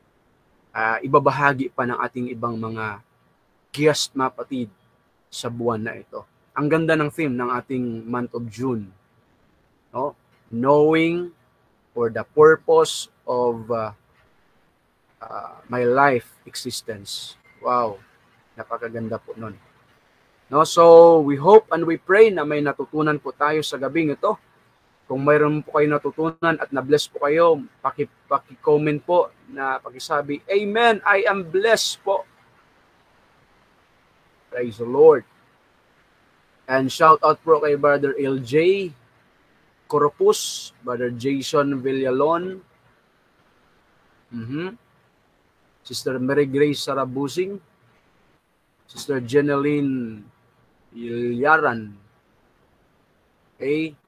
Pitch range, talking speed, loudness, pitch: 125-155 Hz, 105 wpm, -20 LUFS, 140 Hz